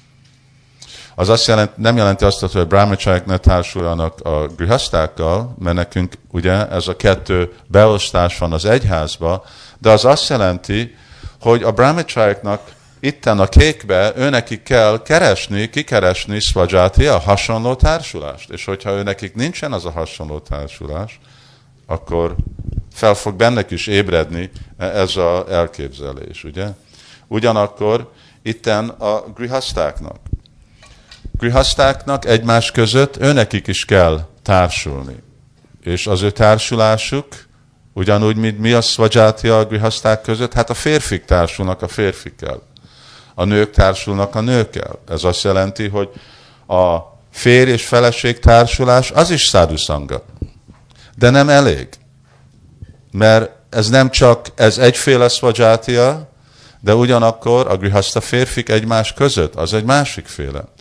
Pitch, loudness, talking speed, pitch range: 110 Hz, -14 LUFS, 125 wpm, 95-125 Hz